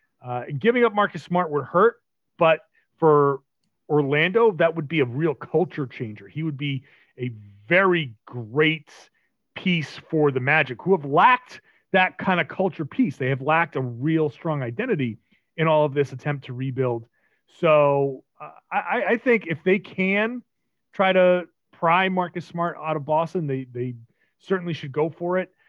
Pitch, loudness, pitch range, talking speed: 155 Hz, -22 LUFS, 140-180 Hz, 170 wpm